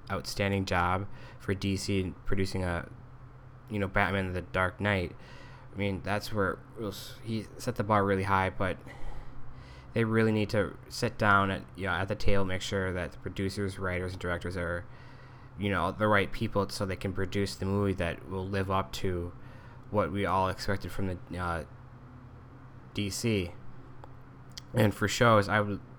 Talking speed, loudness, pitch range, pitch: 170 wpm, -31 LUFS, 95-120 Hz, 100 Hz